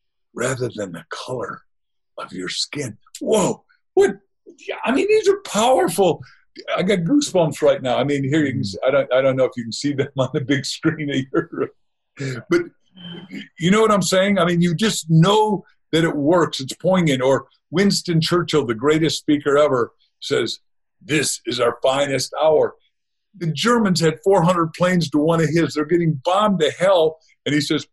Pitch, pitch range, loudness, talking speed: 165 Hz, 145-195 Hz, -19 LUFS, 185 wpm